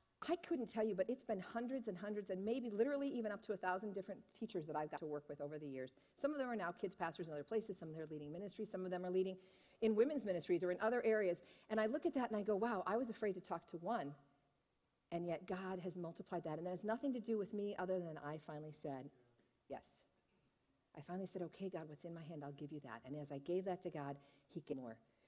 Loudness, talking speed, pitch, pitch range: -44 LUFS, 275 wpm, 185 Hz, 155-215 Hz